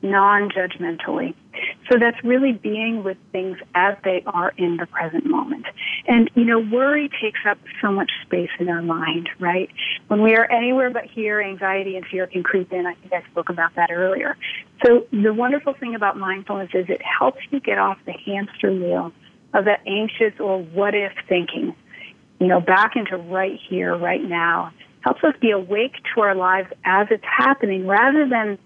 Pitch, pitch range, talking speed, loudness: 200 Hz, 185-235 Hz, 185 wpm, -20 LUFS